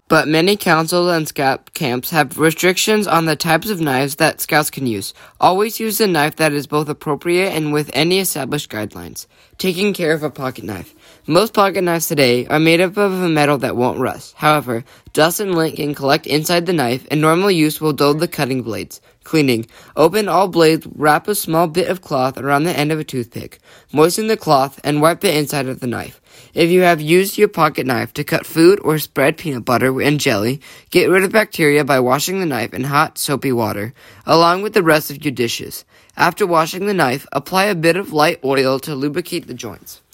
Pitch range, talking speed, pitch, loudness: 135-175 Hz, 210 wpm, 155 Hz, -16 LUFS